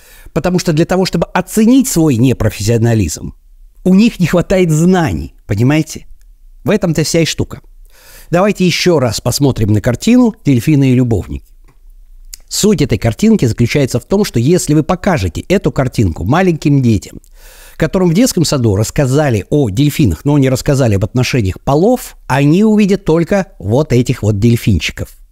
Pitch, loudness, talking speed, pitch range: 145 Hz, -12 LUFS, 145 wpm, 115-180 Hz